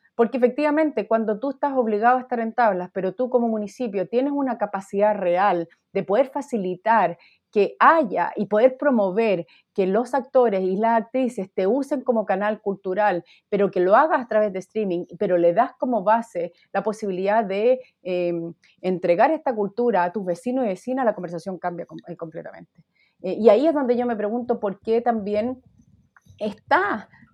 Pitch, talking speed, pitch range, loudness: 215 Hz, 170 wpm, 190-245 Hz, -22 LUFS